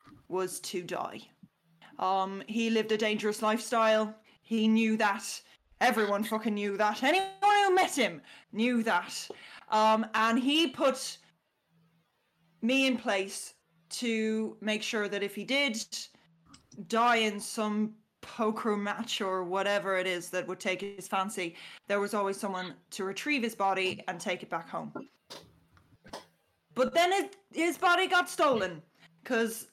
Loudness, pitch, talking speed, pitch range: -30 LUFS, 215 Hz, 145 wpm, 190-230 Hz